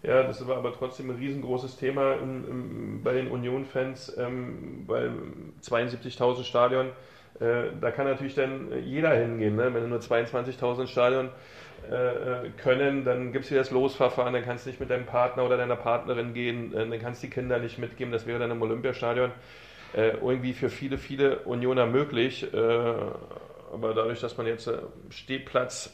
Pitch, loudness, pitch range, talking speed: 125 Hz, -29 LUFS, 120-130 Hz, 175 wpm